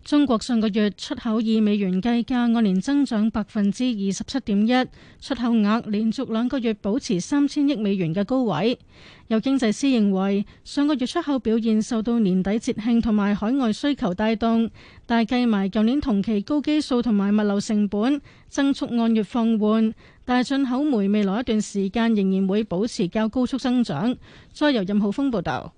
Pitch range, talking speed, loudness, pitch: 210-255 Hz, 280 characters per minute, -22 LUFS, 225 Hz